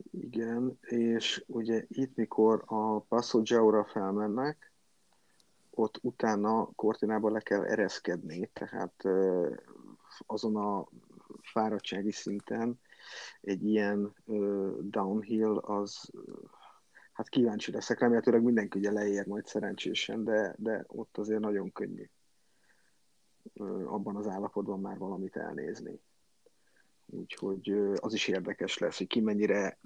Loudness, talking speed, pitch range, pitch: -32 LUFS, 105 wpm, 100-110 Hz, 105 Hz